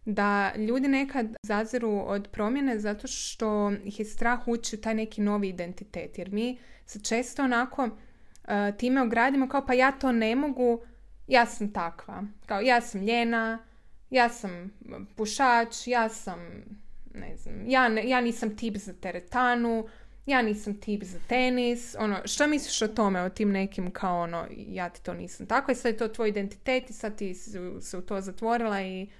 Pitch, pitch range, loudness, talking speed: 220 Hz, 205-245 Hz, -28 LUFS, 175 wpm